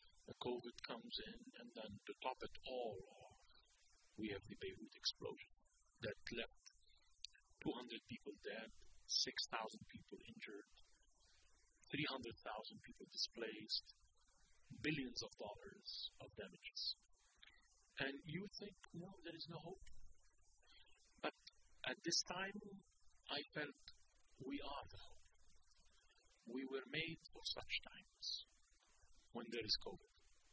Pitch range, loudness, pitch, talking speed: 125-195 Hz, -49 LUFS, 165 Hz, 125 wpm